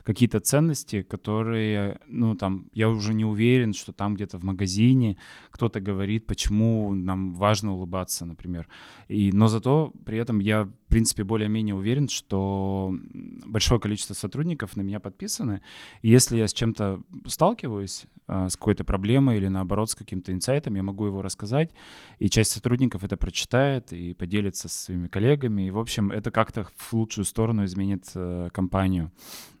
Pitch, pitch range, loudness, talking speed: 105 Hz, 95-115 Hz, -25 LUFS, 155 wpm